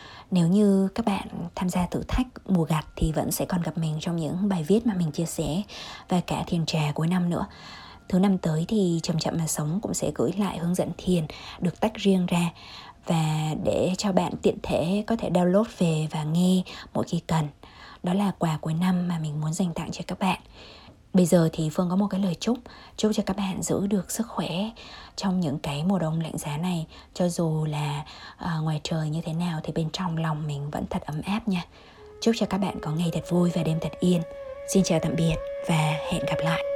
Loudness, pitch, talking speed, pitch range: -26 LUFS, 175 Hz, 230 wpm, 160-195 Hz